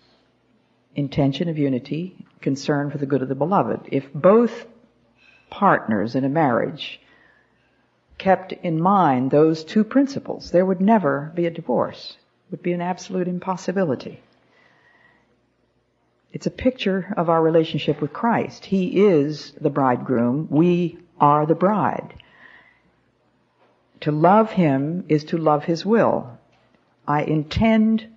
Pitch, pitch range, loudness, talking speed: 170 Hz, 145-190 Hz, -21 LUFS, 130 wpm